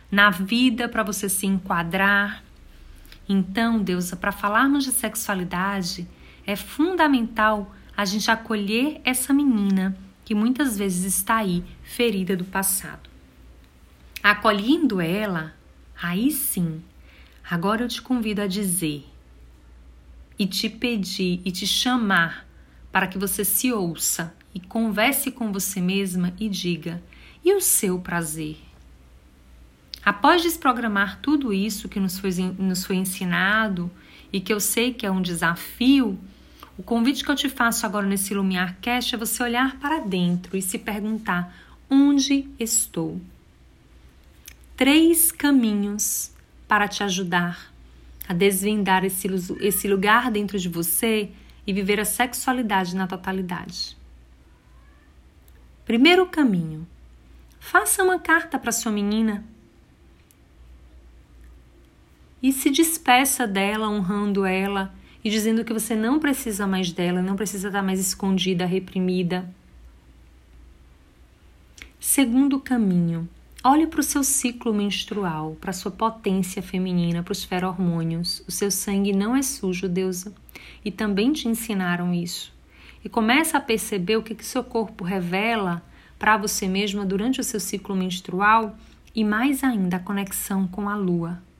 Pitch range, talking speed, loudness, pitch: 175-225 Hz, 130 wpm, -22 LUFS, 195 Hz